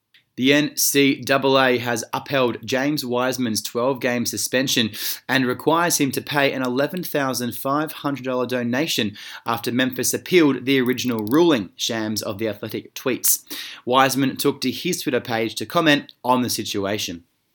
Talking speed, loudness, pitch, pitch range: 135 wpm, -21 LUFS, 130 Hz, 120-140 Hz